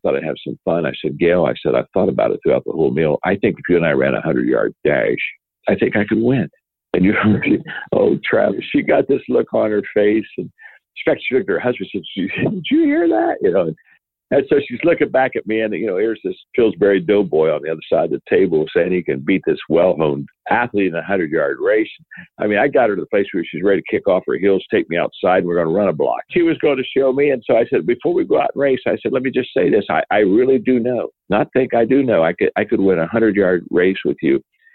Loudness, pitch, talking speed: -17 LUFS, 125 Hz, 275 wpm